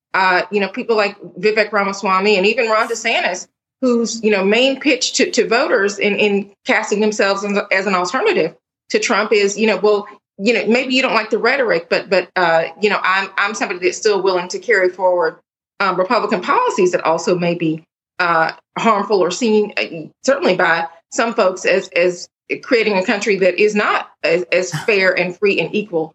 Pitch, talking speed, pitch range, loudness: 205 Hz, 195 wpm, 185-225 Hz, -16 LUFS